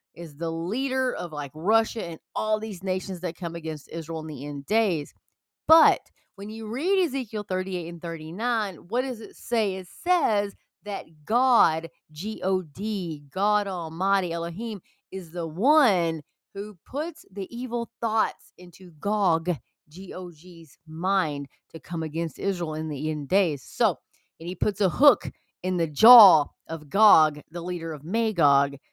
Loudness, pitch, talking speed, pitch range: -25 LUFS, 185 Hz, 155 wpm, 165-215 Hz